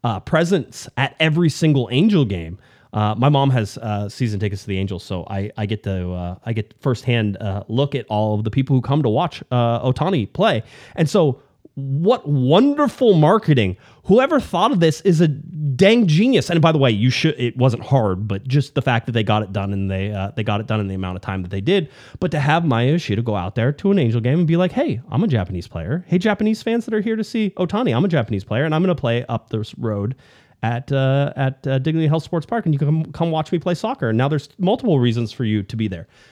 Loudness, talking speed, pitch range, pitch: -19 LUFS, 255 wpm, 110-160 Hz, 135 Hz